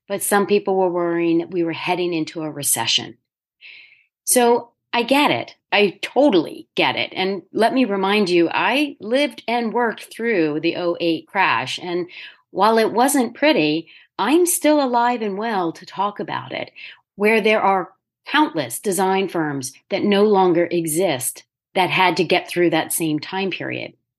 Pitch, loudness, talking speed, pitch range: 190 Hz, -19 LUFS, 165 wpm, 170-235 Hz